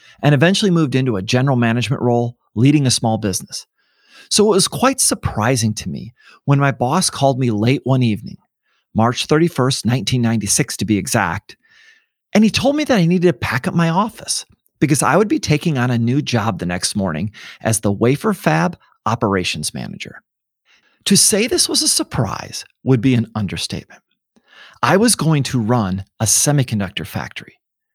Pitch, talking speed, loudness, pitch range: 130 Hz, 175 wpm, -16 LUFS, 115-180 Hz